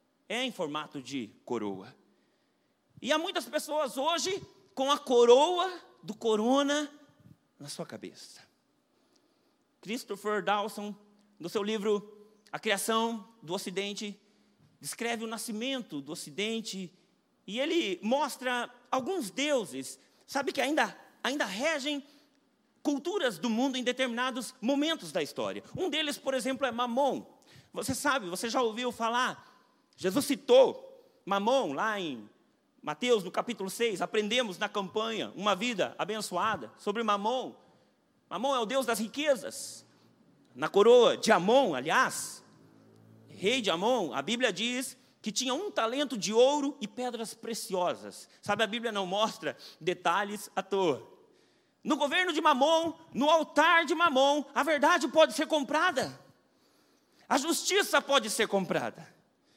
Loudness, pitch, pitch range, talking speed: -30 LUFS, 250 Hz, 210-295 Hz, 130 wpm